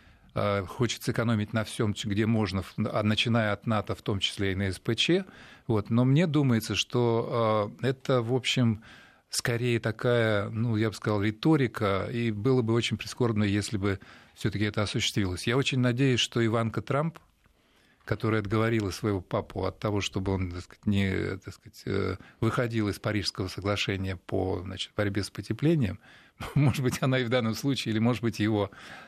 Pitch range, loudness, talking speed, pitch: 100-120 Hz, -28 LUFS, 165 wpm, 110 Hz